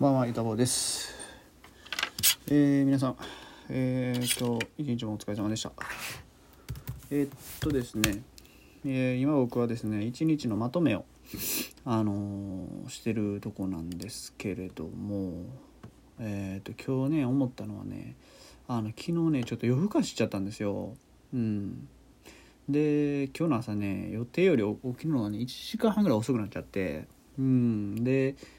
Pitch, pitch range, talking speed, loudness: 120 Hz, 105-135 Hz, 275 characters per minute, -30 LUFS